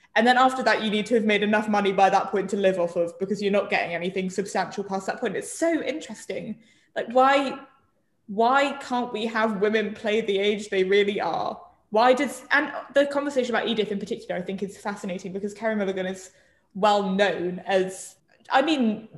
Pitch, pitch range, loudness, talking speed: 210 Hz, 195-245 Hz, -24 LUFS, 205 wpm